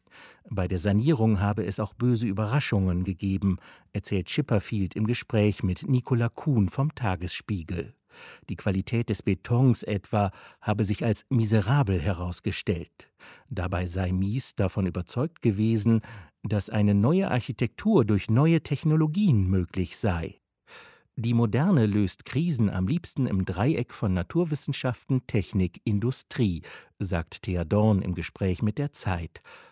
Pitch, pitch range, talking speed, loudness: 105 Hz, 95-125 Hz, 125 wpm, -27 LUFS